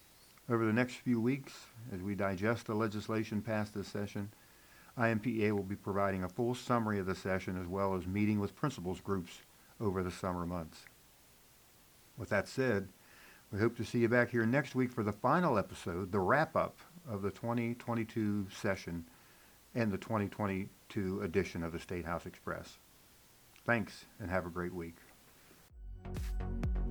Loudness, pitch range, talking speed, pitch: -36 LUFS, 95-115 Hz, 160 wpm, 100 Hz